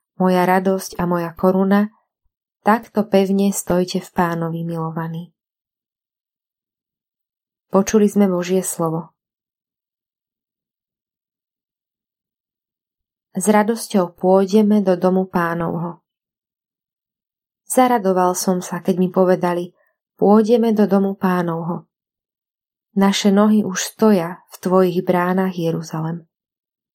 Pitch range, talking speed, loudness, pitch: 175-200 Hz, 85 wpm, -18 LUFS, 185 Hz